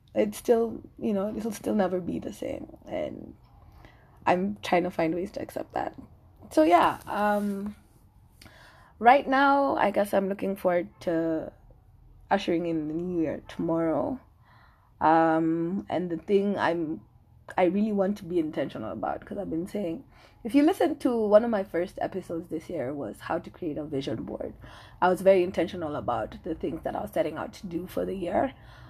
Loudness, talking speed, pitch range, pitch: -27 LUFS, 180 wpm, 165-205 Hz, 180 Hz